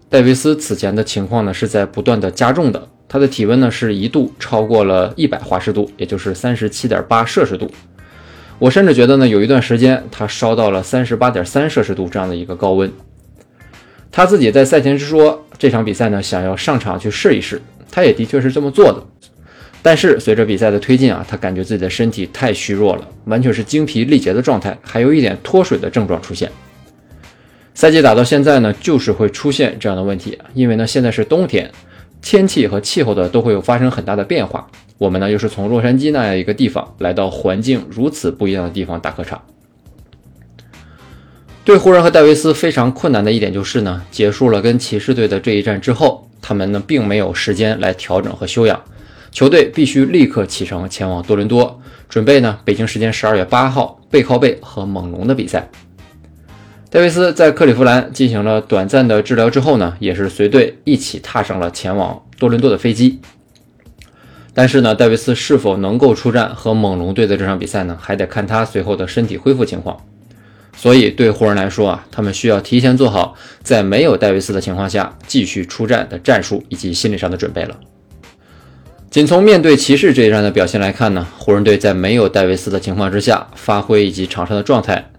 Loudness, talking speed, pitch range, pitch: -13 LUFS, 315 characters per minute, 95-125 Hz, 105 Hz